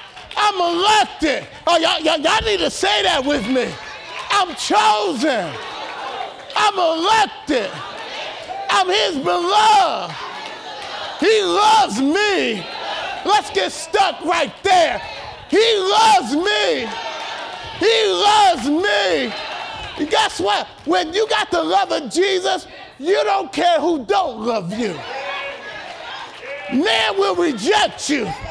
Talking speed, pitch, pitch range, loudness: 115 wpm, 370 Hz, 315-410 Hz, -17 LUFS